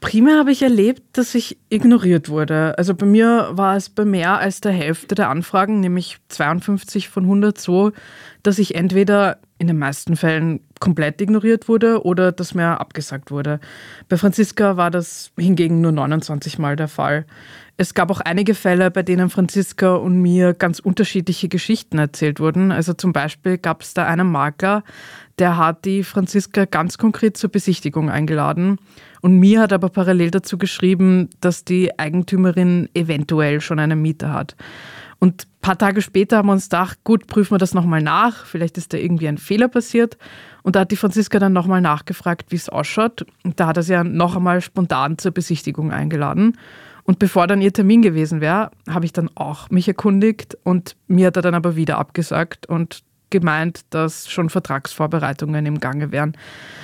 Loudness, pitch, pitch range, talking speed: -17 LUFS, 180 Hz, 160-200 Hz, 180 wpm